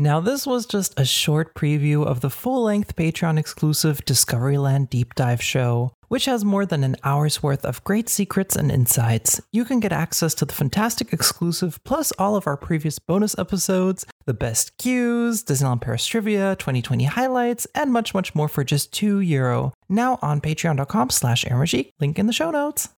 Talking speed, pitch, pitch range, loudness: 175 wpm, 155 Hz, 140-210 Hz, -21 LUFS